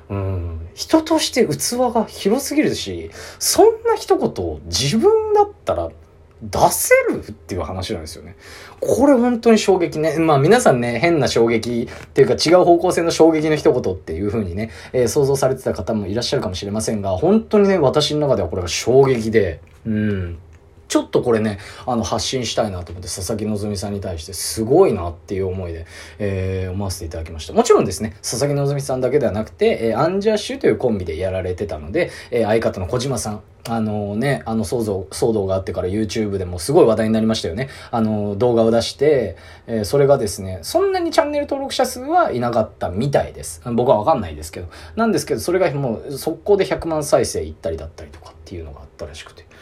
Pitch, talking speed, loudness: 115 Hz, 435 characters per minute, -18 LUFS